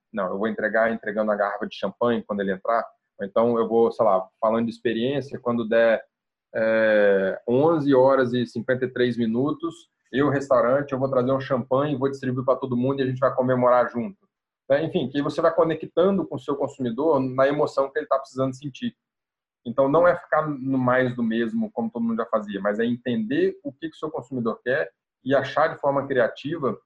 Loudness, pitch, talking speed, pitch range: -23 LUFS, 130 Hz, 205 wpm, 115-140 Hz